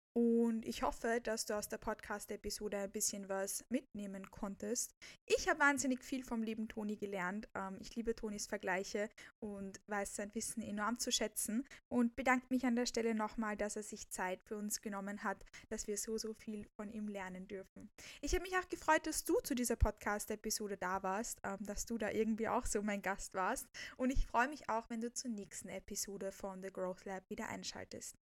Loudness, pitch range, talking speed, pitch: -40 LUFS, 200-235 Hz, 195 wpm, 215 Hz